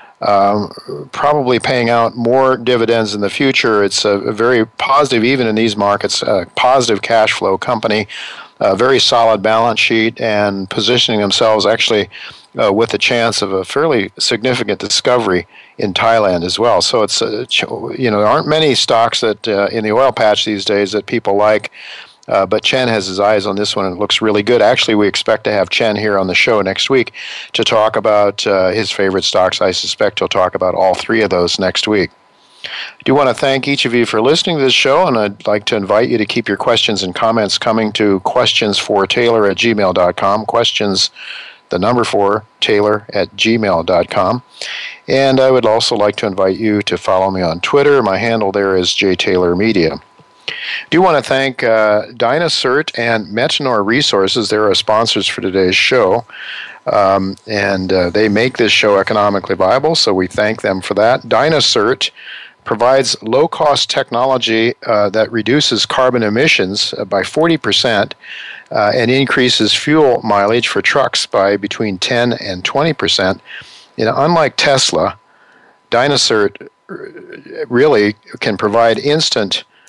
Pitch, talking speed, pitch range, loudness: 105 Hz, 175 wpm, 100-120 Hz, -13 LUFS